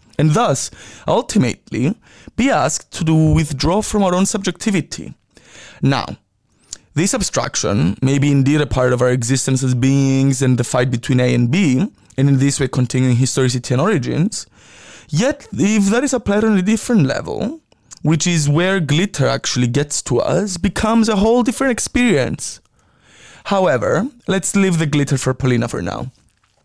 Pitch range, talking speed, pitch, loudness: 130-200 Hz, 160 wpm, 150 Hz, -16 LUFS